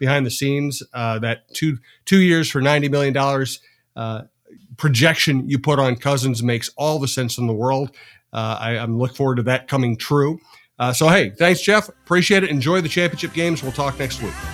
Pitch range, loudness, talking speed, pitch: 125-155 Hz, -19 LUFS, 200 wpm, 140 Hz